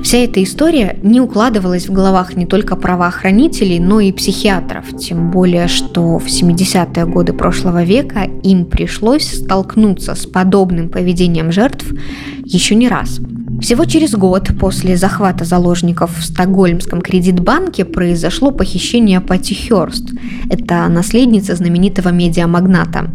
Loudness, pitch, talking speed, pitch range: -12 LUFS, 185 Hz, 125 wpm, 175-210 Hz